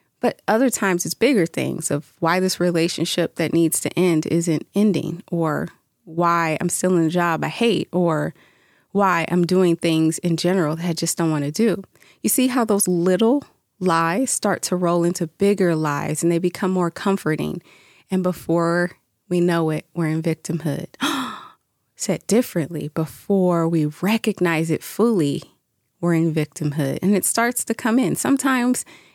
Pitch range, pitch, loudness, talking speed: 165-195 Hz, 175 Hz, -21 LUFS, 165 wpm